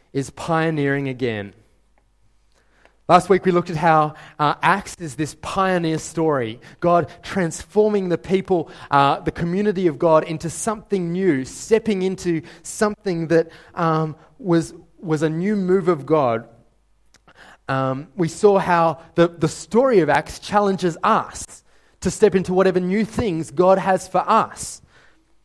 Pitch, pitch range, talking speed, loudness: 170 Hz, 155-190 Hz, 140 wpm, -20 LUFS